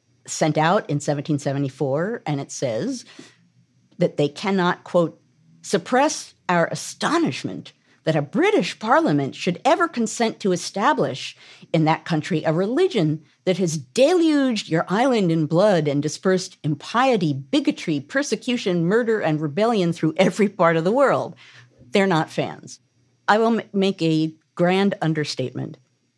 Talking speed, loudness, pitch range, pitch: 135 wpm, -21 LUFS, 155-215 Hz, 175 Hz